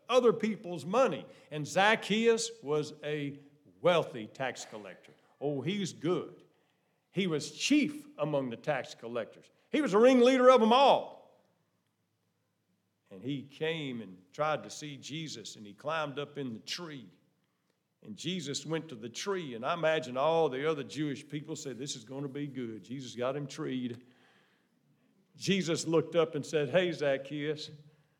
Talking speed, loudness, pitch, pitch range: 155 wpm, -31 LUFS, 150 Hz, 140-175 Hz